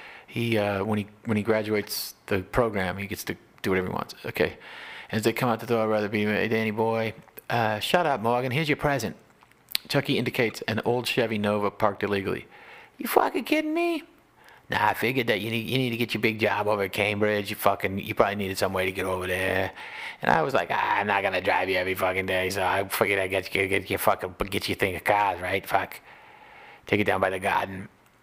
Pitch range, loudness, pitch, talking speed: 100-120 Hz, -26 LUFS, 105 Hz, 240 wpm